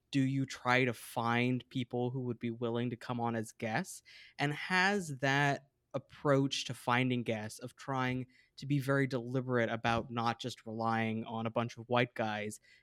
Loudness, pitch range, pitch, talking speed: -34 LUFS, 115-135 Hz, 125 Hz, 180 wpm